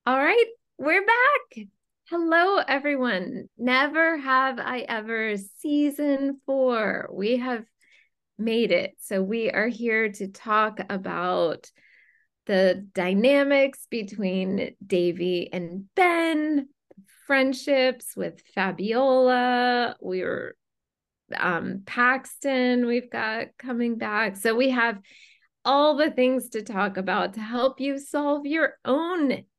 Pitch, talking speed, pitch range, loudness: 250 Hz, 110 wpm, 210-275 Hz, -24 LUFS